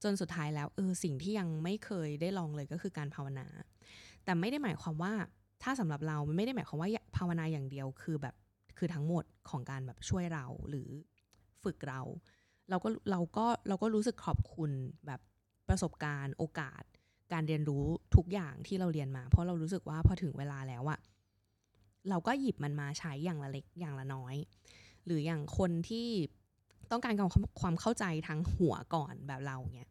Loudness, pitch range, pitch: -37 LUFS, 130-180 Hz, 155 Hz